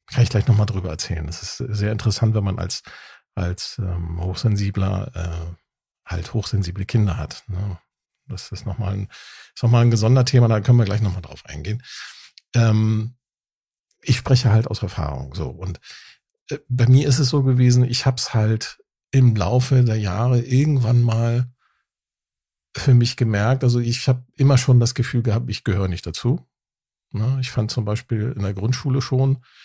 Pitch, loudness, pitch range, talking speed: 115 Hz, -20 LUFS, 100-125 Hz, 175 wpm